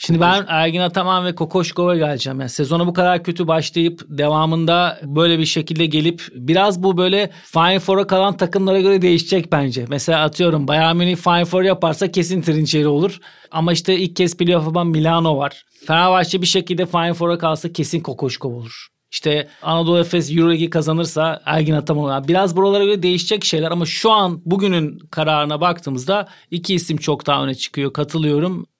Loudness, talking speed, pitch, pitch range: -17 LUFS, 165 wpm, 170 Hz, 155-180 Hz